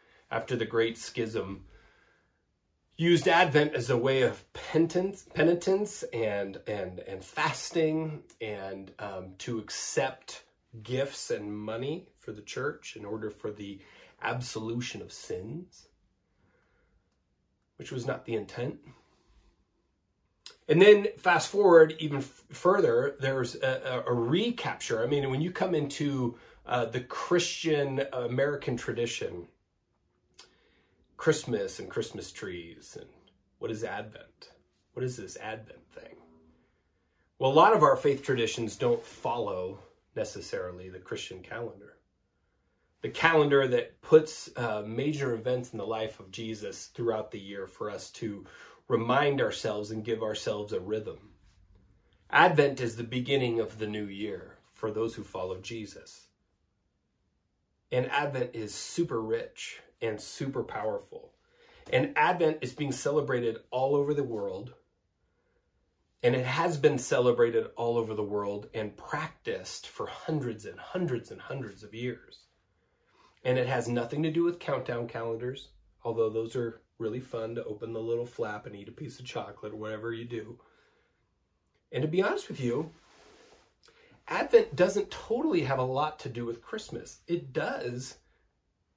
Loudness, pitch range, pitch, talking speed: -30 LUFS, 110-160 Hz, 125 Hz, 140 wpm